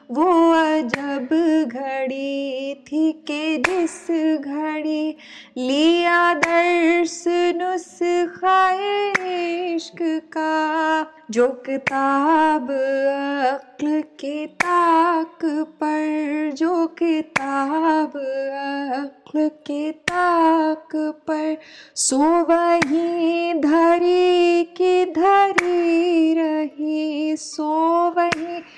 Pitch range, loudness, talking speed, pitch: 295-340 Hz, -20 LUFS, 65 wpm, 315 Hz